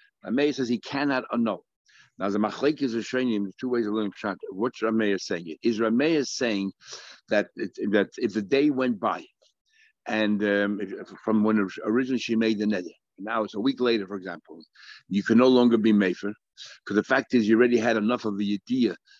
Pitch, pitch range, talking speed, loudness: 115 Hz, 105-125 Hz, 205 wpm, -25 LUFS